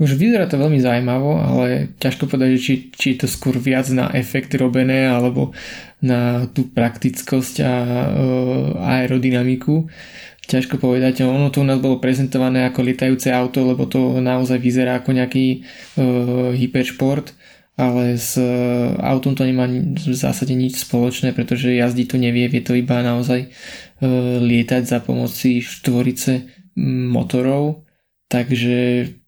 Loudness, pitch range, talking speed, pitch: -18 LUFS, 125-130 Hz, 140 wpm, 130 Hz